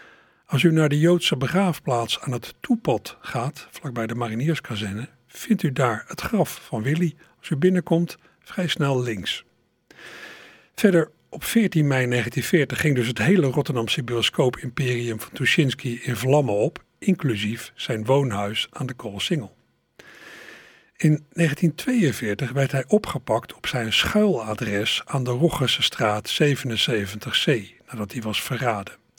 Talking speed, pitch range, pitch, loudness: 130 wpm, 120-165 Hz, 135 Hz, -23 LUFS